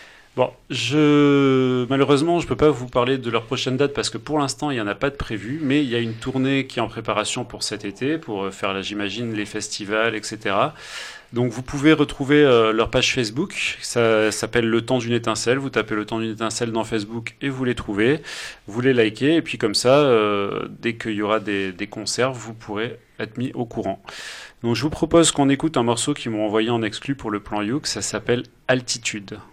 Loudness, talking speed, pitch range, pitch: -21 LUFS, 225 wpm, 110-135 Hz, 120 Hz